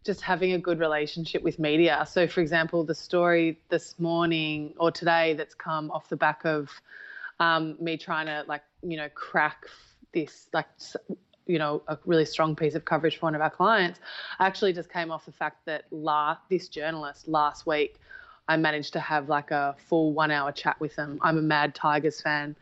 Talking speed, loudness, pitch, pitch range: 200 wpm, -27 LUFS, 160 Hz, 150-170 Hz